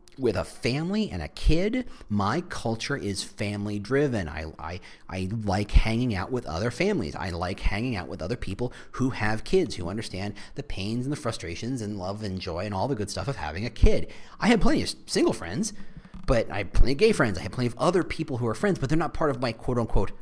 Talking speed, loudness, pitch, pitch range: 235 wpm, -28 LUFS, 115 Hz, 100-140 Hz